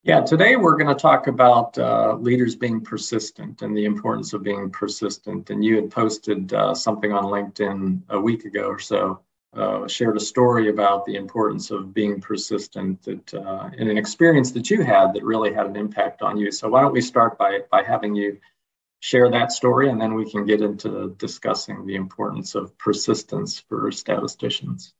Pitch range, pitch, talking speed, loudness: 100-120 Hz, 105 Hz, 190 wpm, -21 LUFS